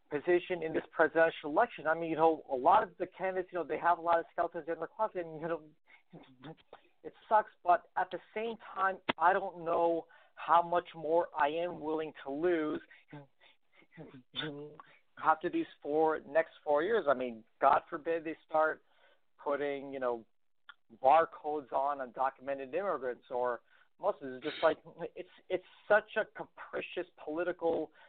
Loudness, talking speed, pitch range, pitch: -33 LUFS, 160 wpm, 150-175 Hz, 165 Hz